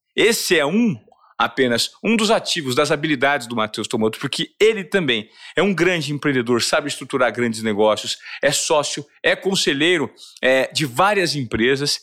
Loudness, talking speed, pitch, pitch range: -19 LUFS, 155 wpm, 145 Hz, 120-185 Hz